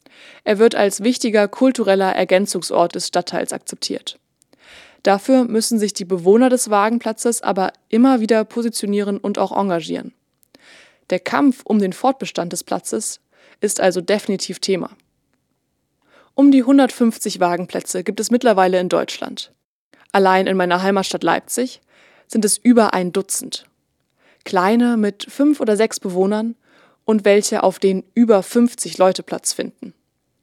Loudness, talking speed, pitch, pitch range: -17 LUFS, 130 wpm, 210 Hz, 190-240 Hz